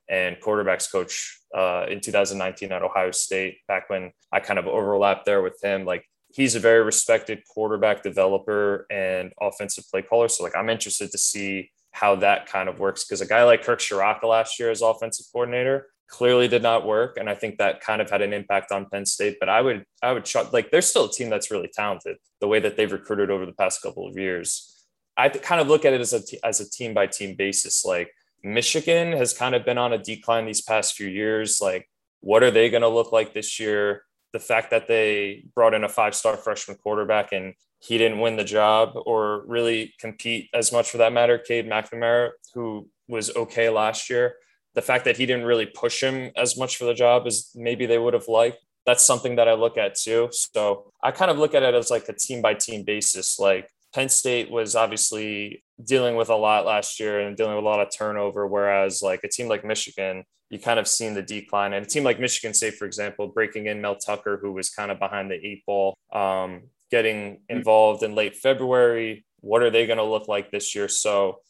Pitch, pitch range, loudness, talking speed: 110 Hz, 100-120 Hz, -23 LUFS, 225 wpm